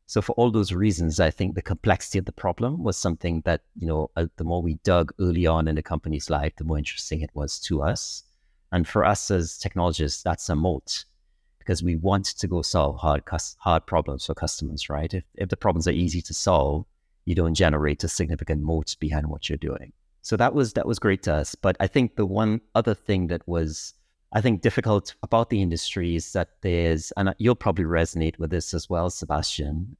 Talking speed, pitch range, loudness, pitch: 215 wpm, 80-95 Hz, -25 LUFS, 85 Hz